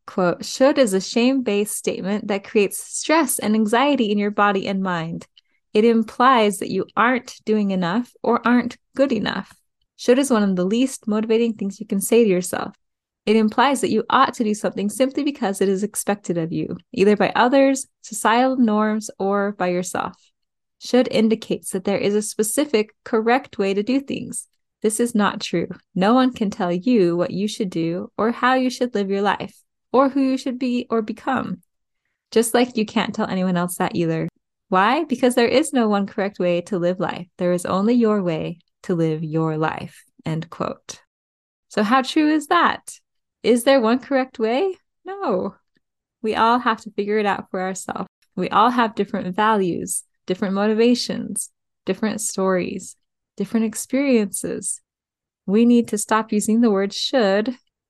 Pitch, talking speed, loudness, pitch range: 215 Hz, 180 wpm, -20 LUFS, 195-245 Hz